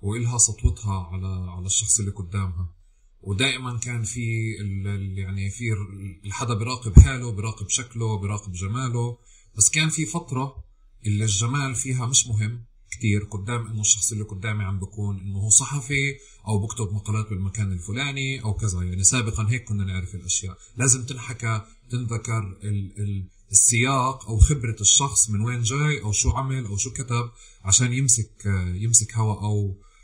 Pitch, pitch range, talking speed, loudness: 110 Hz, 100-120 Hz, 150 wpm, -23 LUFS